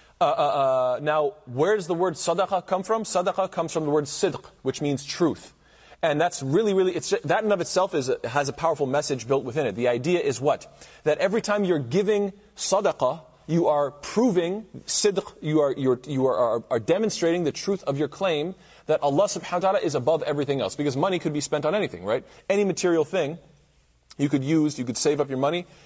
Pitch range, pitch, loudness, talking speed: 145-190 Hz, 165 Hz, -25 LUFS, 220 wpm